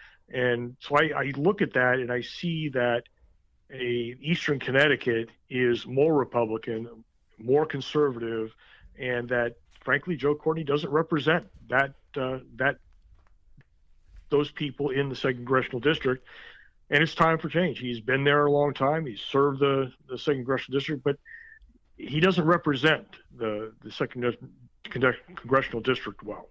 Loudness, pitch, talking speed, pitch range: -27 LUFS, 135 Hz, 145 wpm, 120-150 Hz